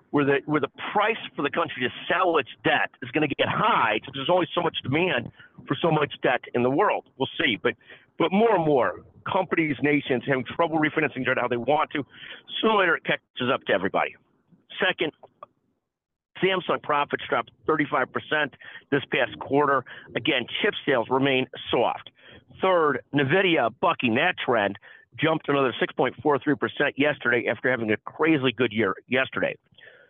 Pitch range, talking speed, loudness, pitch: 130-155 Hz, 165 wpm, -24 LUFS, 145 Hz